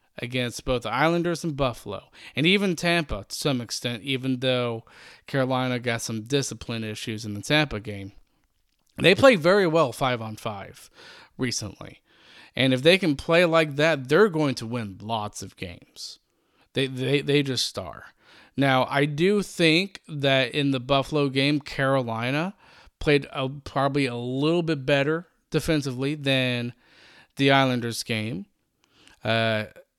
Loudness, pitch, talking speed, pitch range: -24 LUFS, 135 Hz, 145 wpm, 120-150 Hz